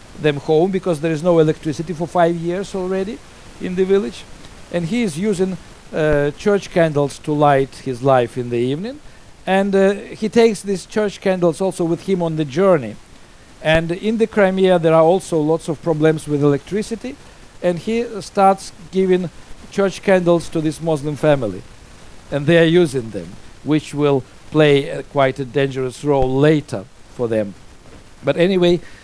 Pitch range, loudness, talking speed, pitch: 145-190 Hz, -18 LUFS, 165 wpm, 165 Hz